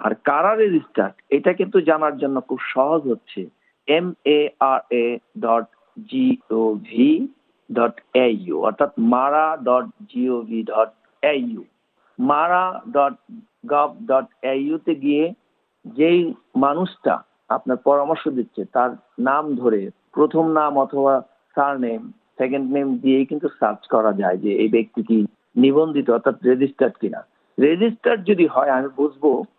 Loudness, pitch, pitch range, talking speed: -20 LUFS, 145 Hz, 130-175 Hz, 105 wpm